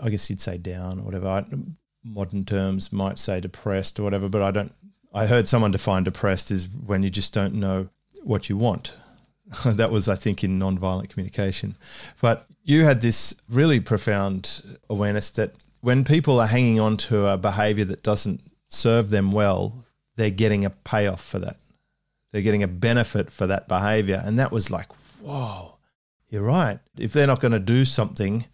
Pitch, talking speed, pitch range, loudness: 105 Hz, 185 wpm, 95-115 Hz, -23 LUFS